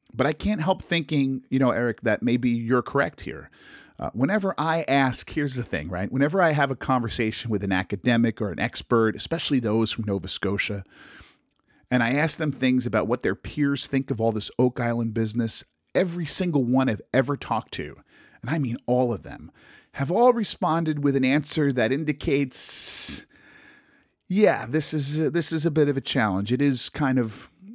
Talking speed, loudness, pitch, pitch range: 190 wpm, -24 LUFS, 130 Hz, 115-150 Hz